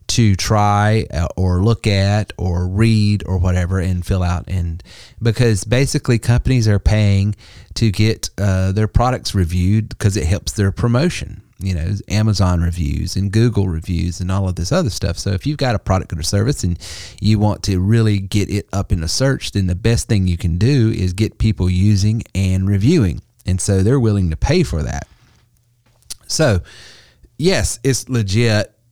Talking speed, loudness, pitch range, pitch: 180 wpm, -17 LUFS, 90-115 Hz, 100 Hz